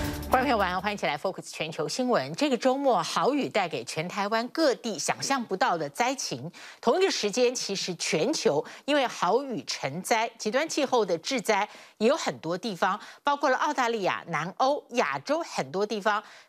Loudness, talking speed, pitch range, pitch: -27 LUFS, 290 characters per minute, 190-260 Hz, 225 Hz